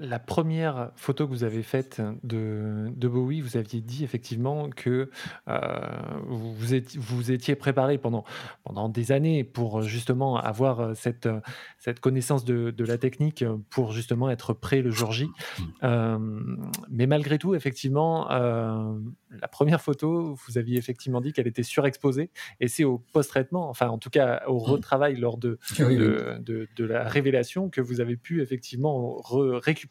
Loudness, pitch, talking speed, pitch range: -27 LUFS, 125 Hz, 165 wpm, 115-140 Hz